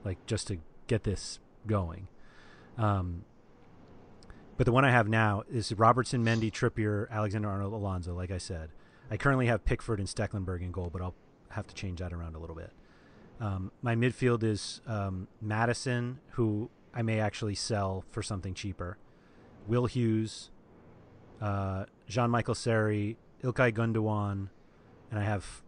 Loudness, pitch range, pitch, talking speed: -32 LUFS, 95-115 Hz, 105 Hz, 155 wpm